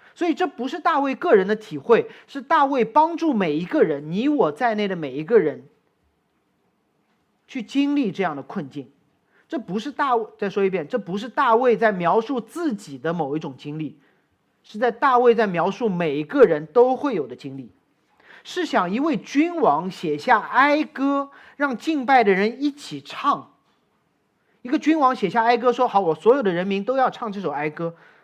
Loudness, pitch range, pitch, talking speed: -21 LUFS, 180-280 Hz, 230 Hz, 260 characters per minute